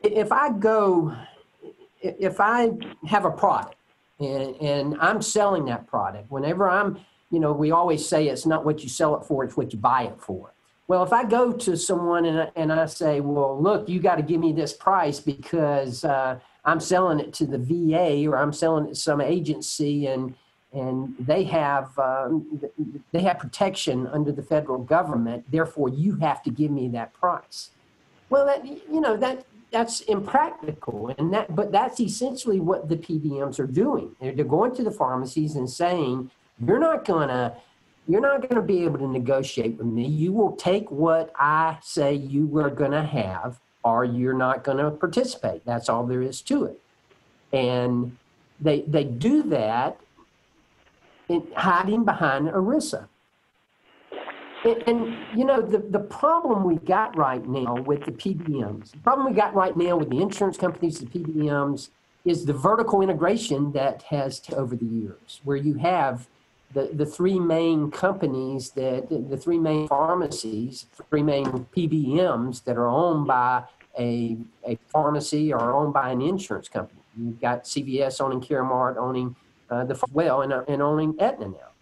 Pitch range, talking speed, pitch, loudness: 135-185 Hz, 175 wpm, 150 Hz, -24 LUFS